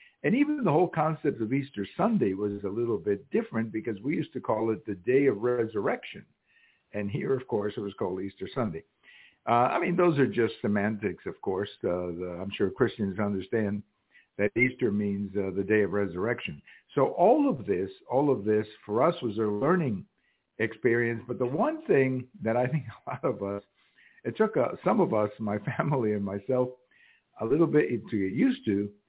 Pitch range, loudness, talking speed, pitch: 100-135 Hz, -28 LUFS, 200 wpm, 115 Hz